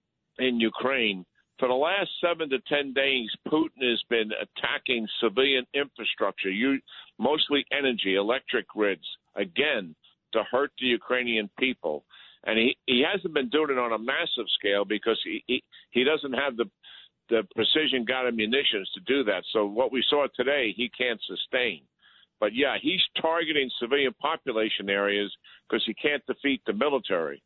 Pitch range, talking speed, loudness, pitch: 110-140 Hz, 155 wpm, -26 LUFS, 130 Hz